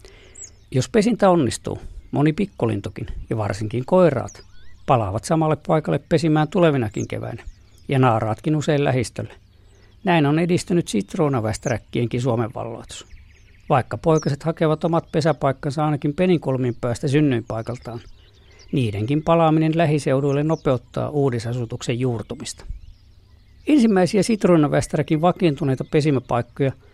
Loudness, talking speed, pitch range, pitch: -21 LUFS, 95 wpm, 110-155 Hz, 130 Hz